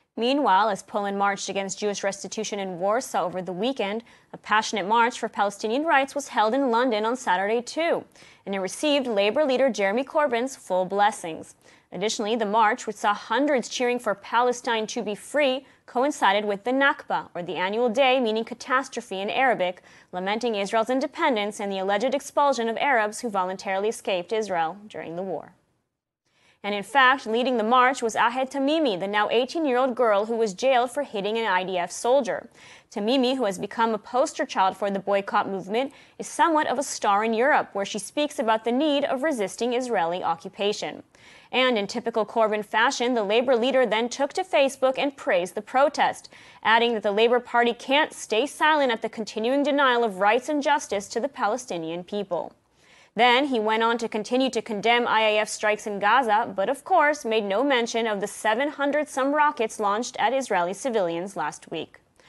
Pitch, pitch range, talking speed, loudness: 230 Hz, 205-260 Hz, 180 wpm, -24 LUFS